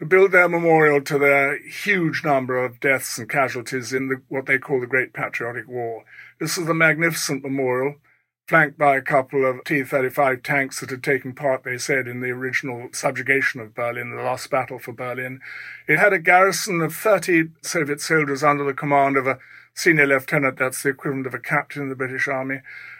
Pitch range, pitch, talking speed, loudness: 130-155 Hz, 140 Hz, 200 wpm, -20 LUFS